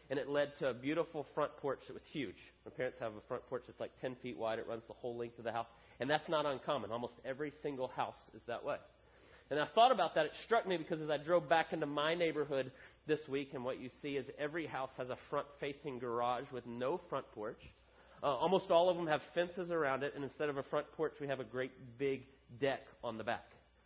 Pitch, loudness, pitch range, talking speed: 135 Hz, -39 LUFS, 125-150 Hz, 250 wpm